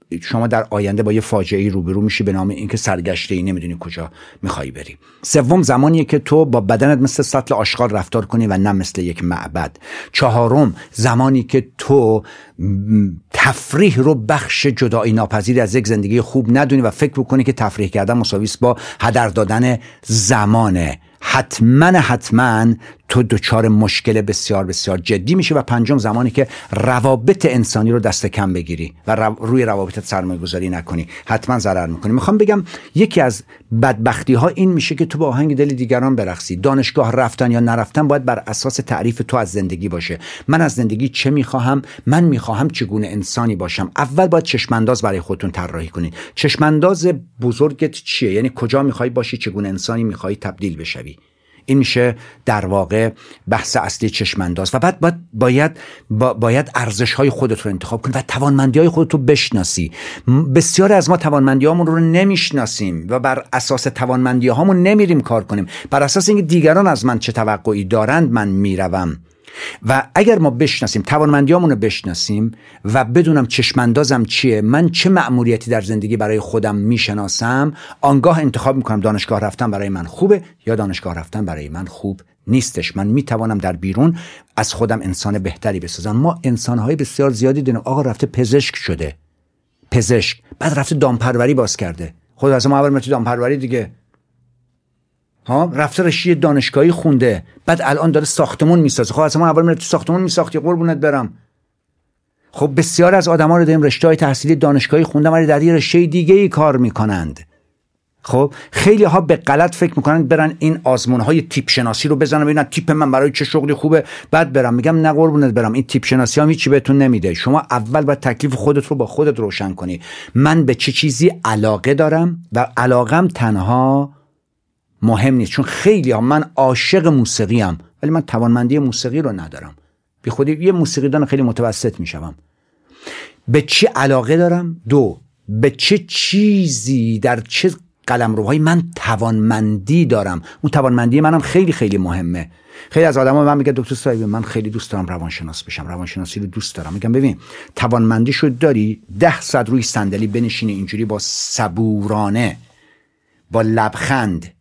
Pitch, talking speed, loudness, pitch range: 125 Hz, 165 wpm, -15 LUFS, 105-150 Hz